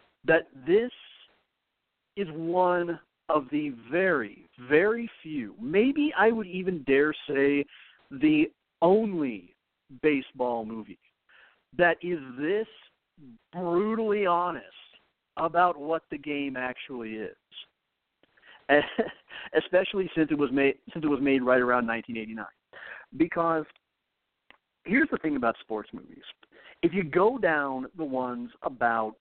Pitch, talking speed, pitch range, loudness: 160 Hz, 115 wpm, 135-190 Hz, -27 LUFS